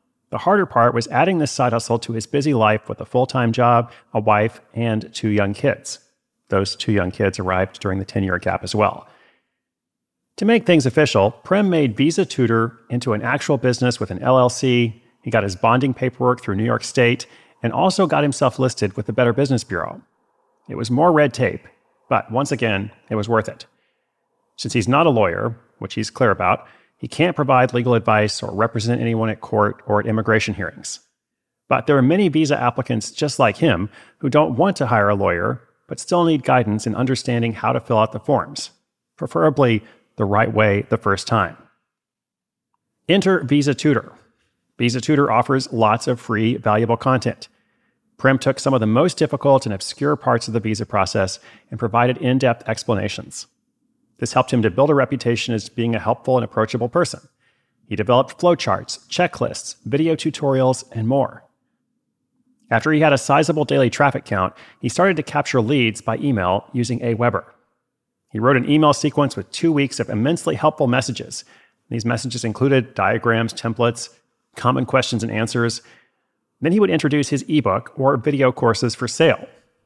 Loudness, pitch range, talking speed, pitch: -19 LUFS, 110-140 Hz, 180 wpm, 120 Hz